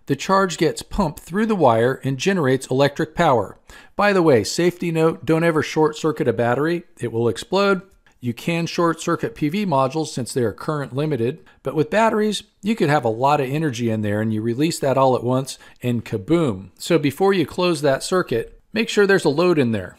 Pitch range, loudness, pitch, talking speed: 130-180 Hz, -20 LUFS, 155 Hz, 210 wpm